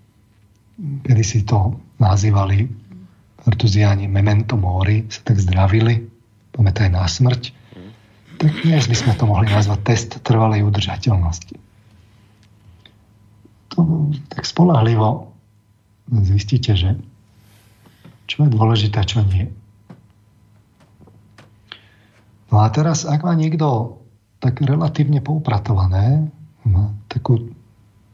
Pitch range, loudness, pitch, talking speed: 105-120 Hz, -17 LUFS, 110 Hz, 95 wpm